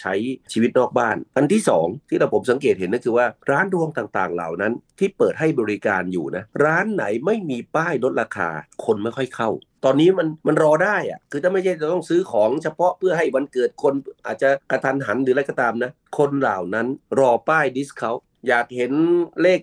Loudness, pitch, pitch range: -21 LUFS, 140 Hz, 125-175 Hz